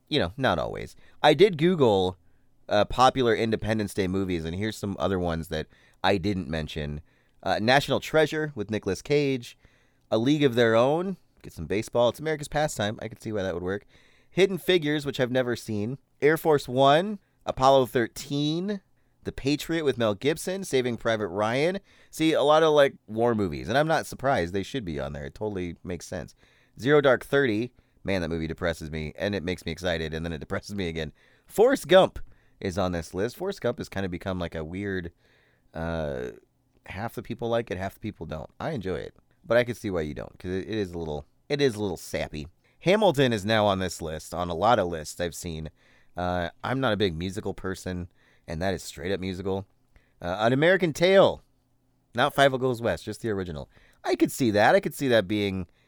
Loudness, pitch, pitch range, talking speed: -26 LUFS, 105 Hz, 90-135 Hz, 210 wpm